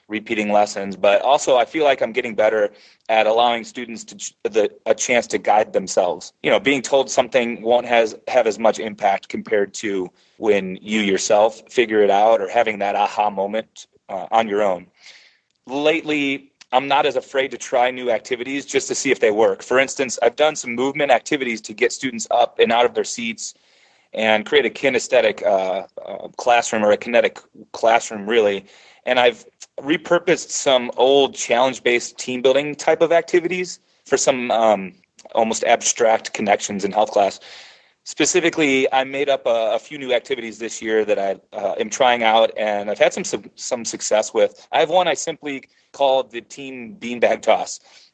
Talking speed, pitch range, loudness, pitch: 185 wpm, 110-155 Hz, -19 LUFS, 125 Hz